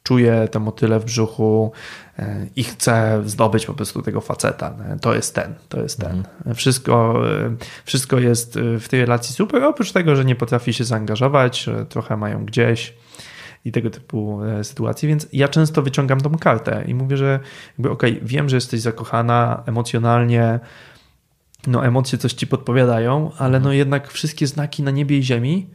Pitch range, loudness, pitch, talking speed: 115-140 Hz, -19 LUFS, 120 Hz, 160 wpm